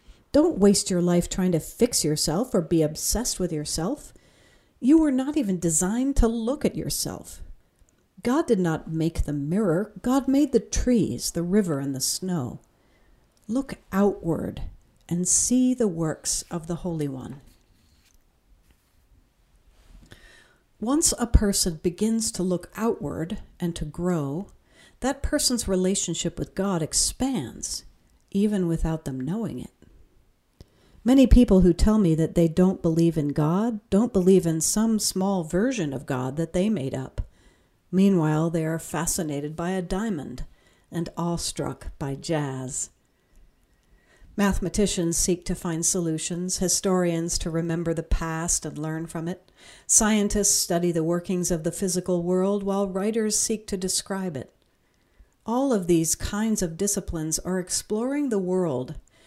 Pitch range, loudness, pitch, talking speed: 160-205 Hz, -24 LUFS, 180 Hz, 140 wpm